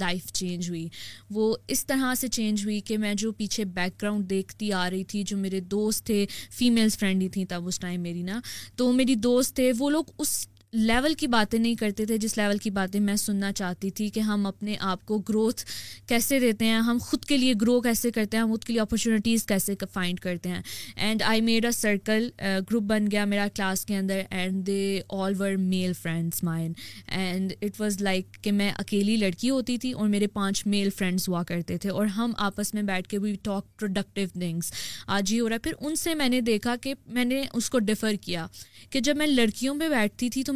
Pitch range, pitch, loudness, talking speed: 195-230 Hz, 210 Hz, -27 LUFS, 220 wpm